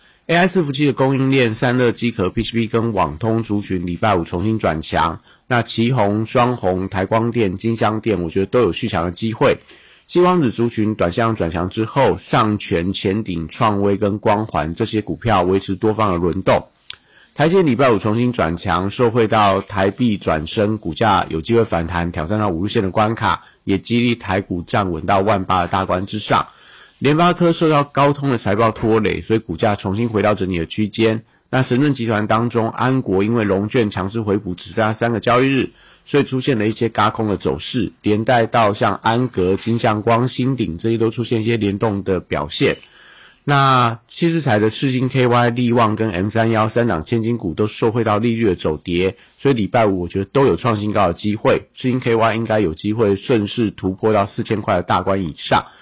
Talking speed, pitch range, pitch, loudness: 300 characters per minute, 95-120 Hz, 110 Hz, -18 LUFS